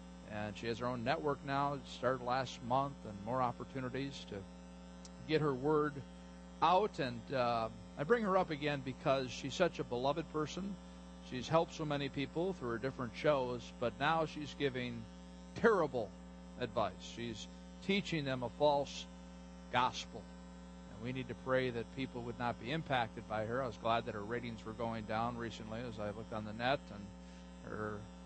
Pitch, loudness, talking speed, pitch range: 120 Hz, -38 LUFS, 180 wpm, 90-140 Hz